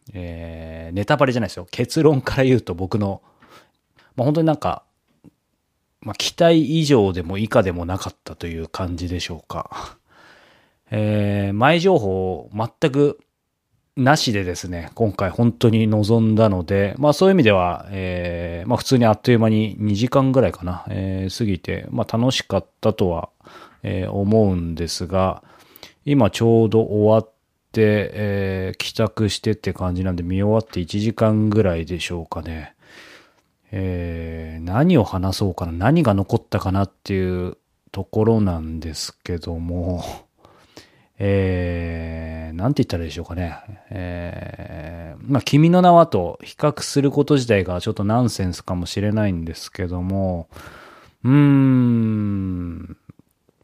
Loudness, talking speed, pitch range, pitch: -20 LUFS, 290 characters per minute, 90-115 Hz, 100 Hz